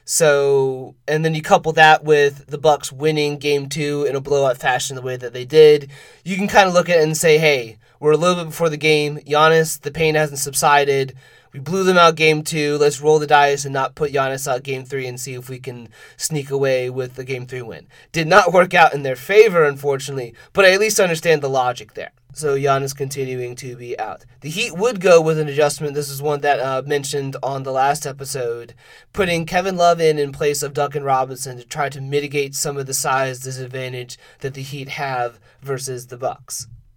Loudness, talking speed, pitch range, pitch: -17 LUFS, 225 wpm, 130-155 Hz, 145 Hz